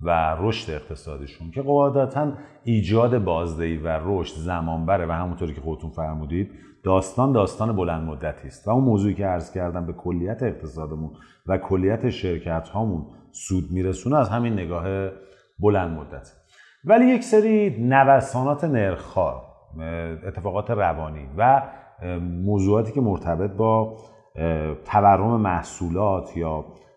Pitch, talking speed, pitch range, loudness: 95 Hz, 120 wpm, 80-115 Hz, -23 LUFS